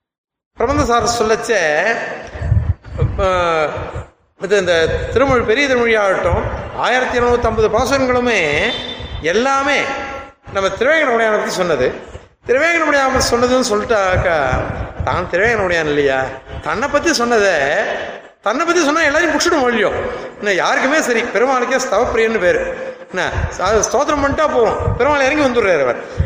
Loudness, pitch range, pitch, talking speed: -15 LUFS, 210-300 Hz, 250 Hz, 100 wpm